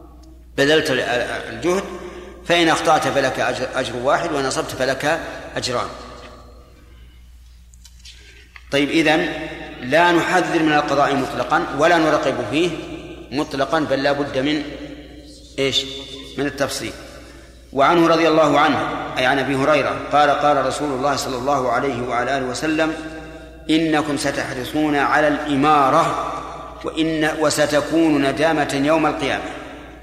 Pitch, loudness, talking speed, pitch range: 145 Hz, -18 LUFS, 110 wpm, 135-160 Hz